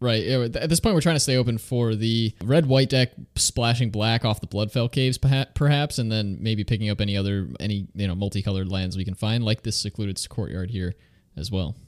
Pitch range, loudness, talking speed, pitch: 100-125 Hz, -24 LUFS, 215 wpm, 110 Hz